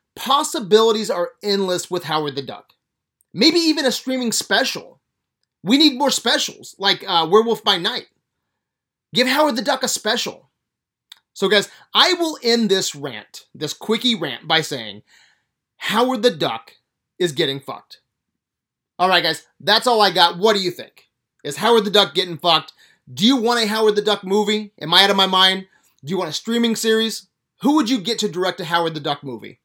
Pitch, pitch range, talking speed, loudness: 200 Hz, 170-235 Hz, 190 wpm, -18 LUFS